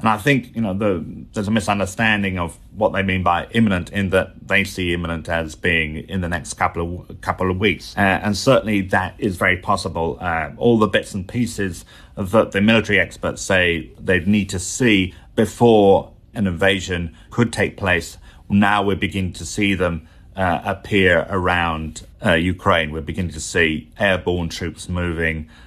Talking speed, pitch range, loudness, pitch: 180 wpm, 85-105 Hz, -19 LUFS, 95 Hz